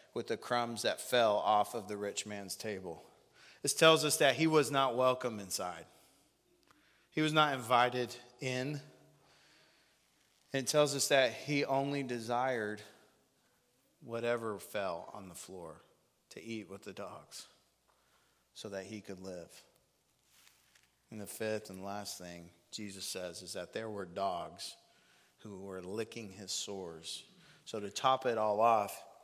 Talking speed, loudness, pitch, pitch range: 145 wpm, -34 LUFS, 115 Hz, 100-130 Hz